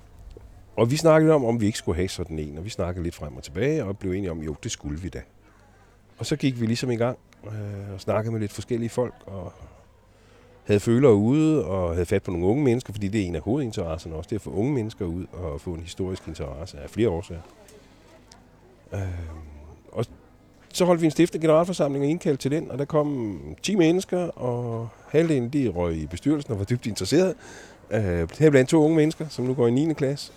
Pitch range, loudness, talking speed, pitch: 90-130 Hz, -24 LUFS, 215 wpm, 105 Hz